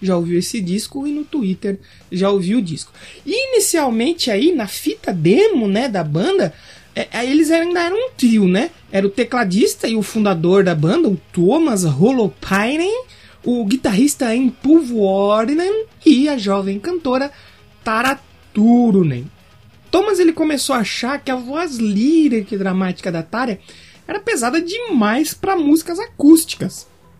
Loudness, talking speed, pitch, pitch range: -17 LUFS, 150 wpm, 240 Hz, 195-315 Hz